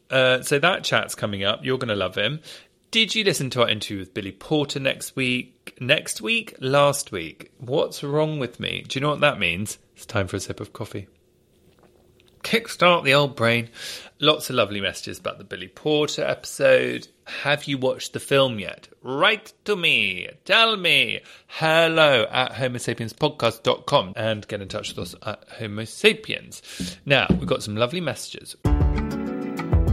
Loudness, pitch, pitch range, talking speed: -22 LUFS, 125 Hz, 105-150 Hz, 170 wpm